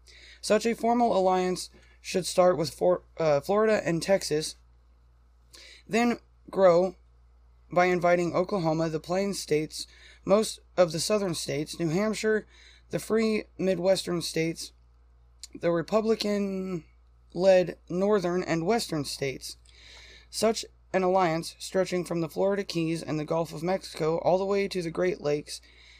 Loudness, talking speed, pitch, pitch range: -27 LUFS, 135 wpm, 175 Hz, 145-190 Hz